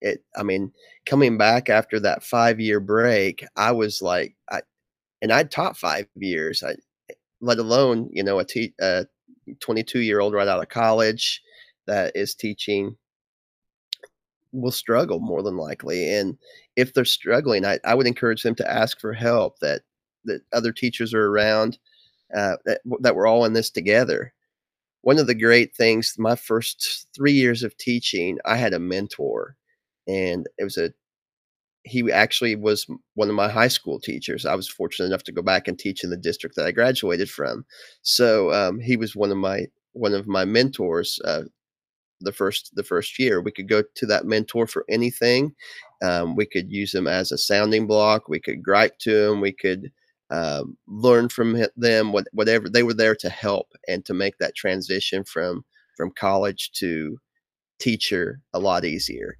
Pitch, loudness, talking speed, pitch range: 115 Hz, -22 LUFS, 175 wpm, 105-125 Hz